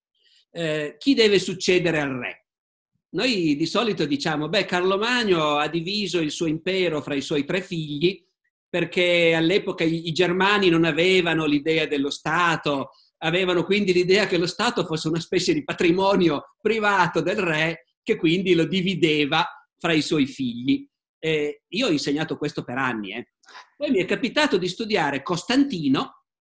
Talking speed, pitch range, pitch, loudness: 160 wpm, 155-195 Hz, 175 Hz, -22 LUFS